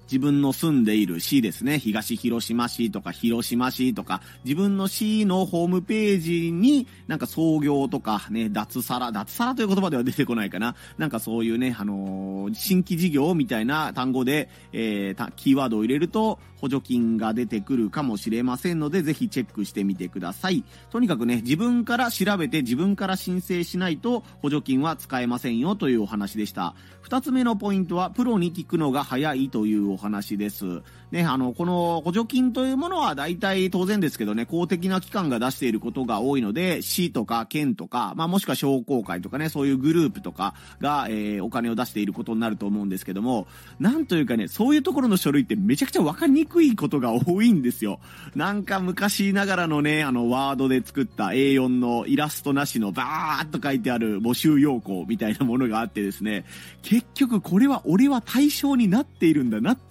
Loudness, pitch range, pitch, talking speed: -24 LUFS, 115-195 Hz, 140 Hz, 400 characters per minute